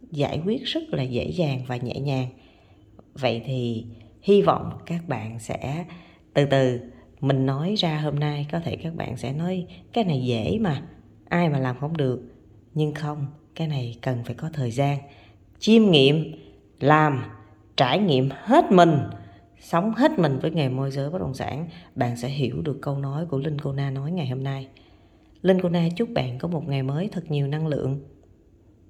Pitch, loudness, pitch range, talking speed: 140 Hz, -24 LUFS, 120-160 Hz, 190 wpm